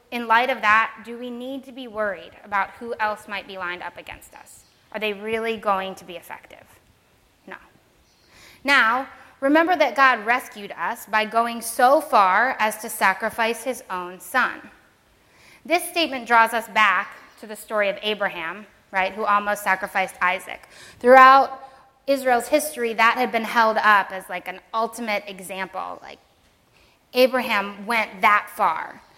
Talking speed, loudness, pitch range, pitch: 155 wpm, -20 LUFS, 200-250 Hz, 225 Hz